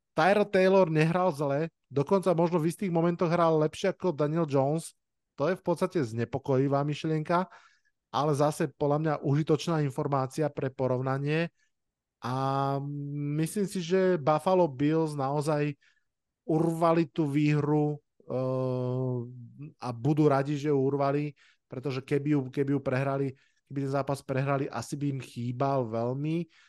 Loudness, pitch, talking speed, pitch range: -29 LUFS, 150 Hz, 135 wpm, 135-165 Hz